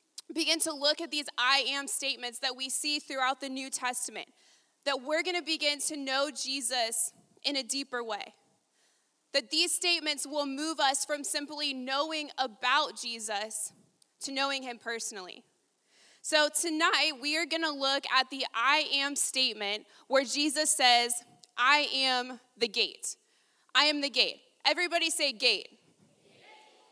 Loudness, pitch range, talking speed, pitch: -29 LUFS, 255-315 Hz, 150 wpm, 280 Hz